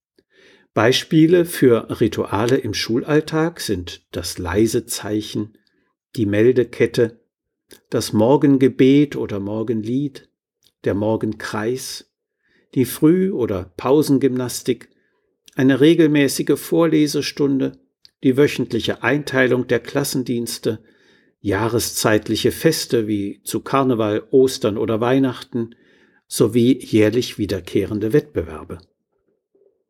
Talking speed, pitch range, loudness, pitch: 80 wpm, 110-145 Hz, -19 LUFS, 125 Hz